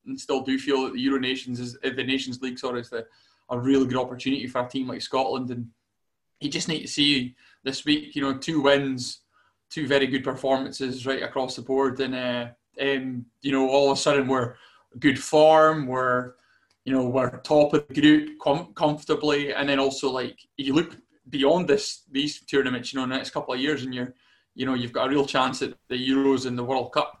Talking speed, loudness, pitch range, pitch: 215 wpm, -25 LUFS, 130-145 Hz, 135 Hz